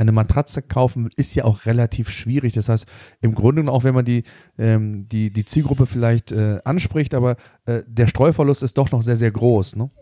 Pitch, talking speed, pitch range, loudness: 120 Hz, 205 wpm, 110-130 Hz, -19 LUFS